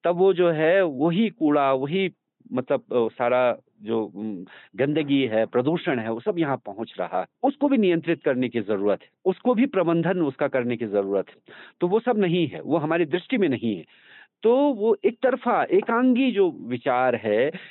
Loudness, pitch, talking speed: -23 LUFS, 170 Hz, 180 wpm